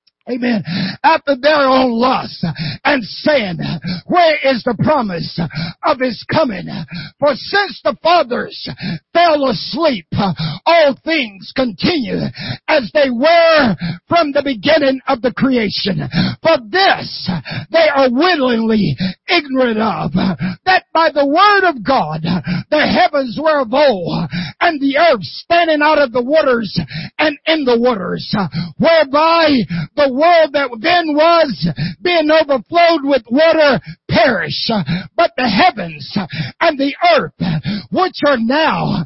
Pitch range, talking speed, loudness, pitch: 185-315 Hz, 125 wpm, -14 LUFS, 265 Hz